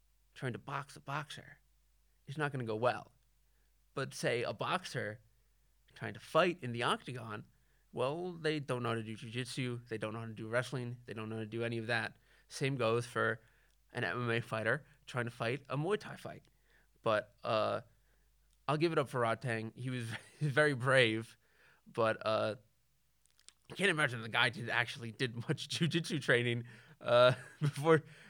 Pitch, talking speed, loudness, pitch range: 125 Hz, 180 wpm, -36 LUFS, 115-145 Hz